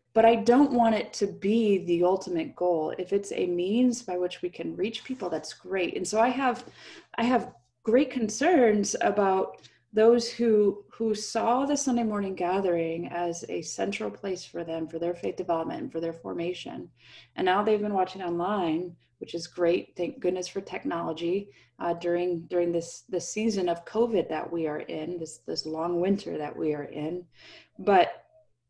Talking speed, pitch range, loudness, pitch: 180 wpm, 170-220 Hz, -28 LUFS, 180 Hz